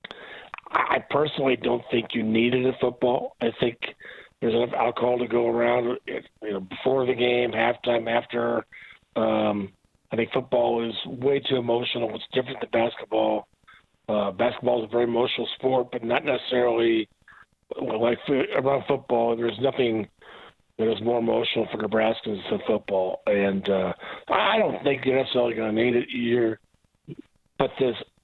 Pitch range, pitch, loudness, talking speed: 110-125 Hz, 120 Hz, -25 LUFS, 155 wpm